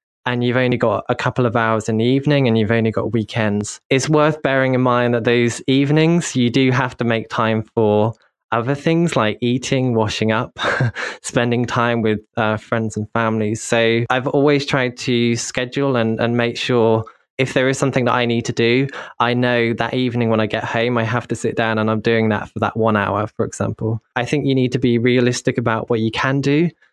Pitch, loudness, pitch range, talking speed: 120 Hz, -18 LUFS, 110-130 Hz, 220 wpm